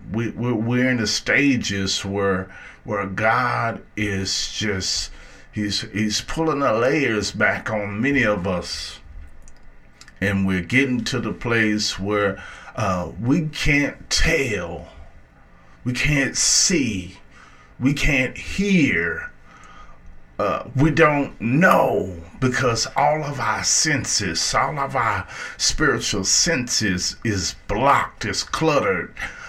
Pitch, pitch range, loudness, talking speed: 105 Hz, 95-130 Hz, -20 LUFS, 110 wpm